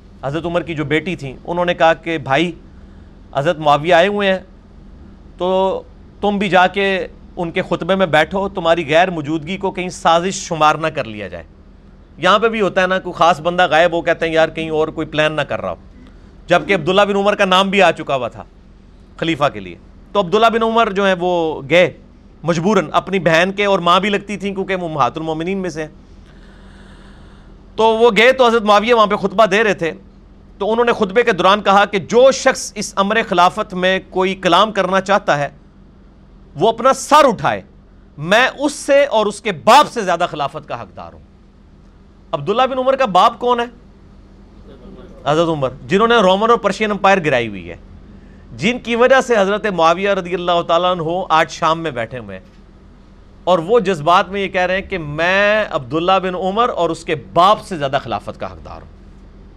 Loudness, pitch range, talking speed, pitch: -15 LUFS, 145-200 Hz, 200 wpm, 175 Hz